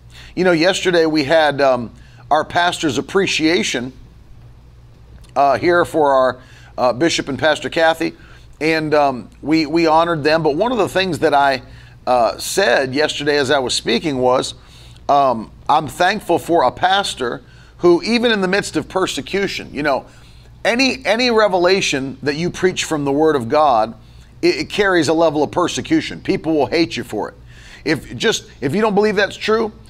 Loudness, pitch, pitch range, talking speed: -16 LUFS, 160 Hz, 135-180 Hz, 175 wpm